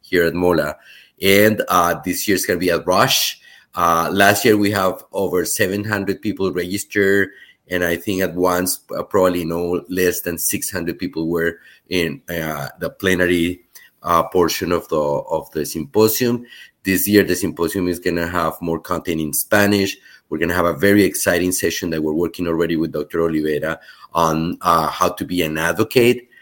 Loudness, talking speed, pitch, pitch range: -18 LUFS, 185 wpm, 90 Hz, 85-100 Hz